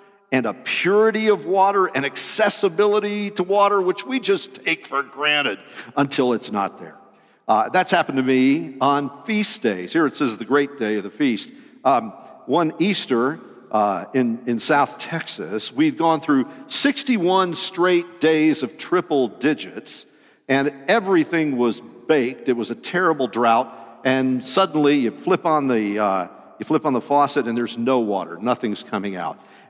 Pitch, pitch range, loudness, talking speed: 145 Hz, 130-195 Hz, -20 LUFS, 165 wpm